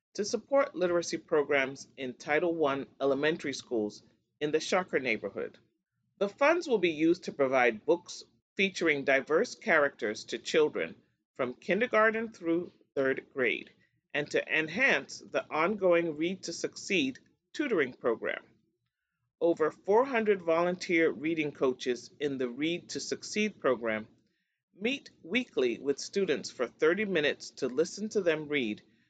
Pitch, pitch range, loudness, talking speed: 170 Hz, 140-215 Hz, -30 LUFS, 130 wpm